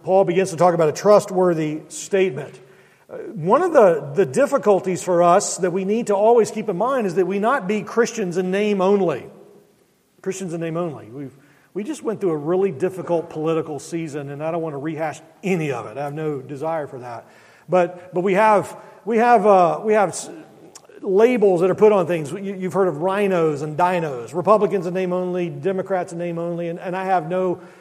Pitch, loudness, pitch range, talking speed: 185 Hz, -20 LUFS, 165-200 Hz, 205 wpm